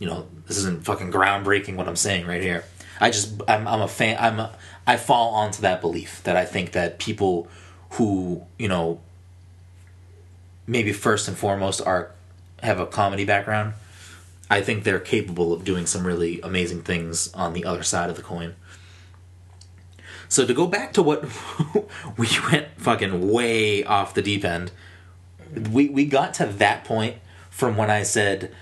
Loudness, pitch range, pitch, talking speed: -23 LUFS, 90-105 Hz, 95 Hz, 170 wpm